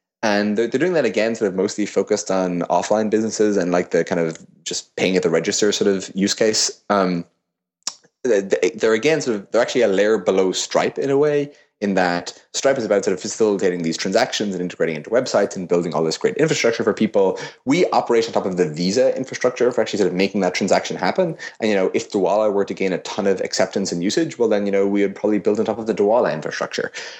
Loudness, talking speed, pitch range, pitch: -20 LUFS, 235 wpm, 90-105 Hz, 100 Hz